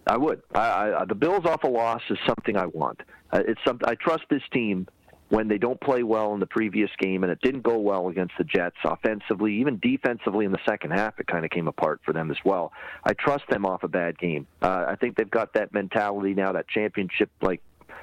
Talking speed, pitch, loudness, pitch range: 235 wpm, 105 Hz, -26 LUFS, 95-120 Hz